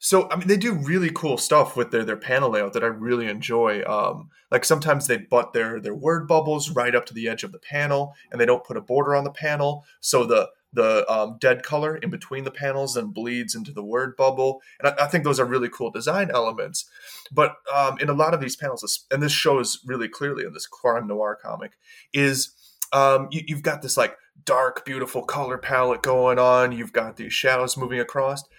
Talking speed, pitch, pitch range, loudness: 225 wpm, 135 Hz, 125-145 Hz, -23 LUFS